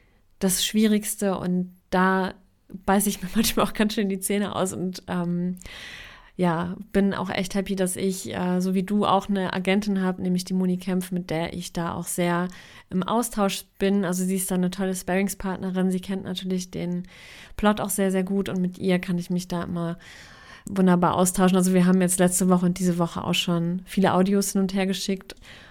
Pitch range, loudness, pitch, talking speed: 180-195 Hz, -24 LUFS, 185 Hz, 205 wpm